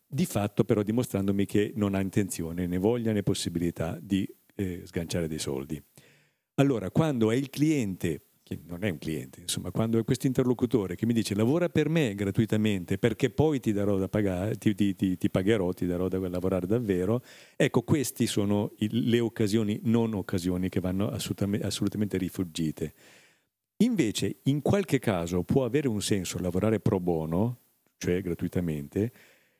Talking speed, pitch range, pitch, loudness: 160 wpm, 90-115 Hz, 105 Hz, -28 LUFS